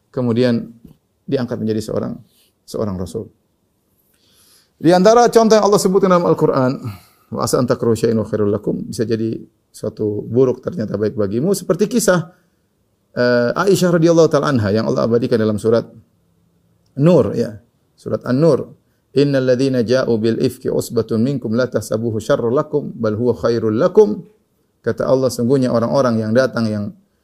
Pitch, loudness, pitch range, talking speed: 120 Hz, -16 LUFS, 110-150 Hz, 145 wpm